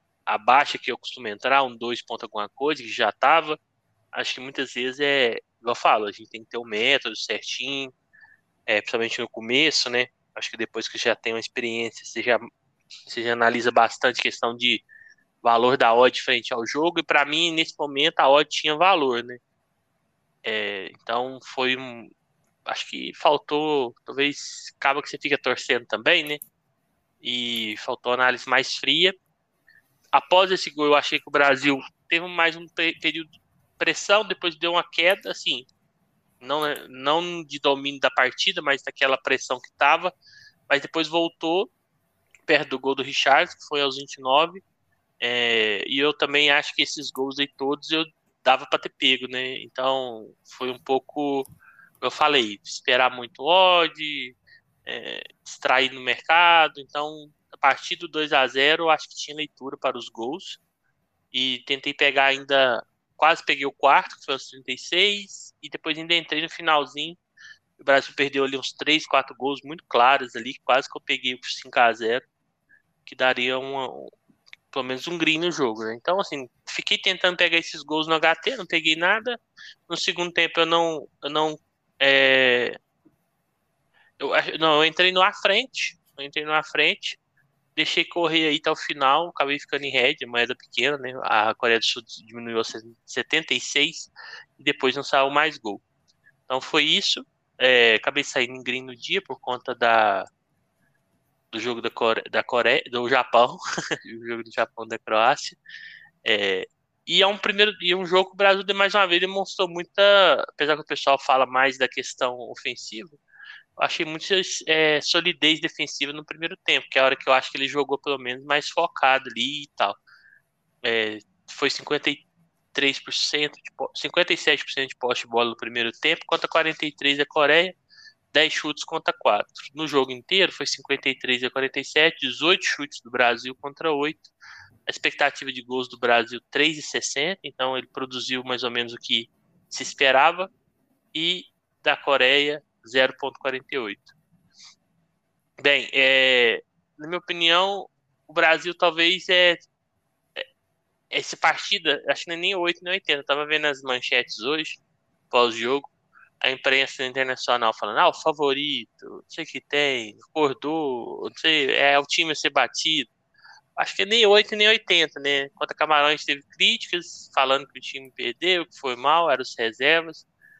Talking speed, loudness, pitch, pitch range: 165 wpm, -22 LUFS, 145 Hz, 130-165 Hz